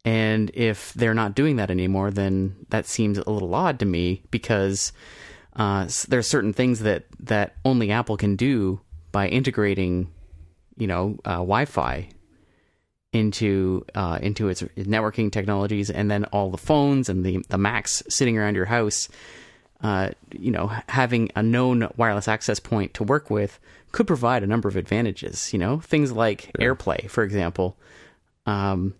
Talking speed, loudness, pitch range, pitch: 165 wpm, -24 LUFS, 95-115 Hz, 105 Hz